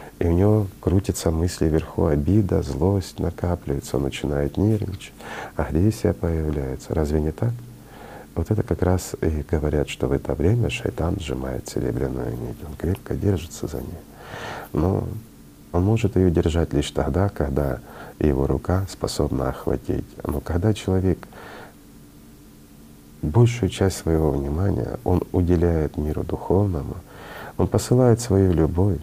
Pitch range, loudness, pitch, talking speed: 75-95 Hz, -23 LUFS, 85 Hz, 130 wpm